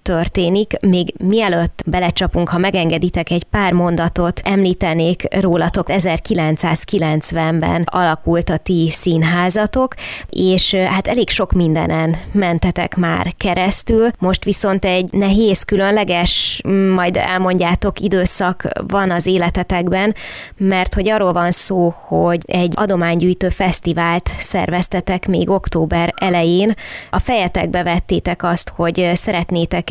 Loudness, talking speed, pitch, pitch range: -15 LUFS, 110 wpm, 180 Hz, 170-190 Hz